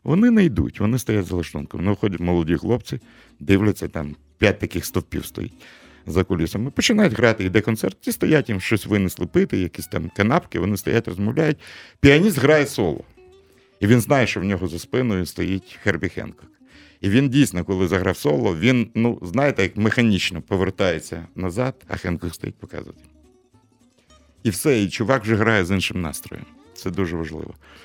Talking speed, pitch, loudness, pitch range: 170 wpm, 100 Hz, -21 LUFS, 90-120 Hz